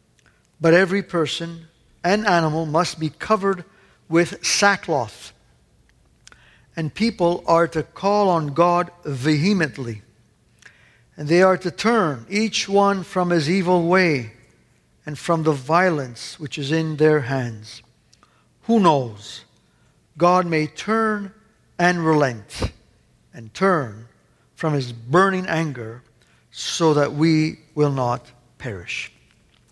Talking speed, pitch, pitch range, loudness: 115 wpm, 160 Hz, 130-180 Hz, -20 LUFS